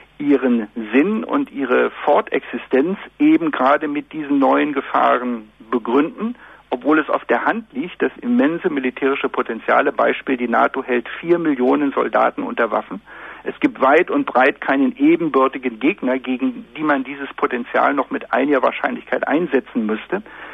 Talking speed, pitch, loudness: 145 wpm, 145 Hz, -18 LUFS